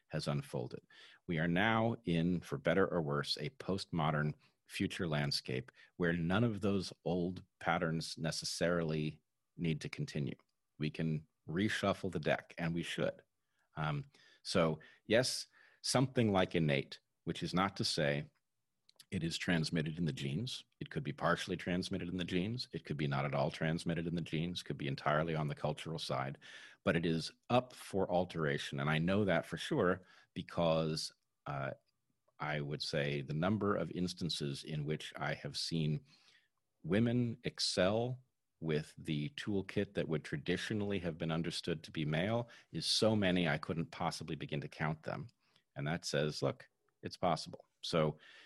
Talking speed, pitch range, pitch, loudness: 165 wpm, 75-95 Hz, 85 Hz, -37 LUFS